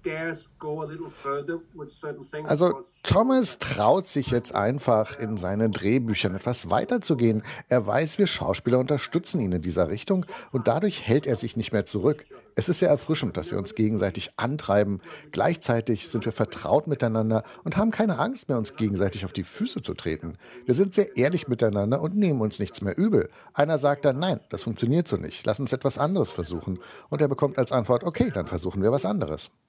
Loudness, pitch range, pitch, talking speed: -25 LUFS, 110-165 Hz, 130 Hz, 180 wpm